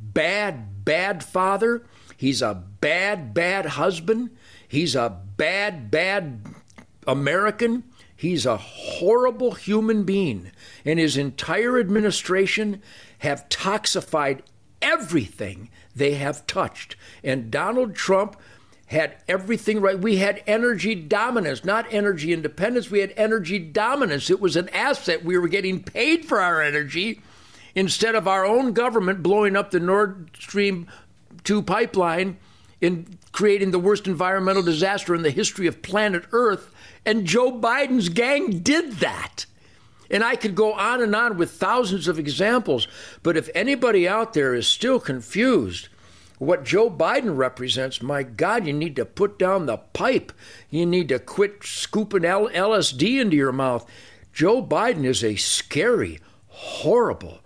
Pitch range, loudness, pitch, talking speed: 150-215 Hz, -22 LUFS, 190 Hz, 140 wpm